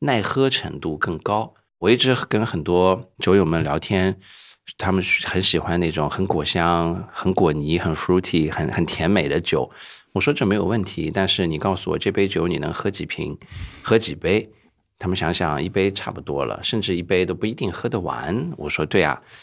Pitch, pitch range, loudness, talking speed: 95 Hz, 85-95 Hz, -21 LUFS, 285 characters per minute